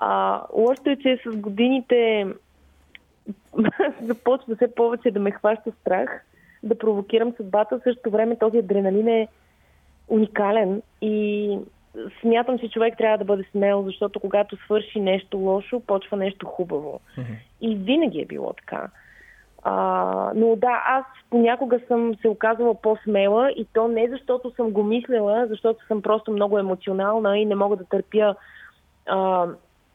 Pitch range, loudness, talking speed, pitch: 200-230 Hz, -22 LUFS, 140 wpm, 215 Hz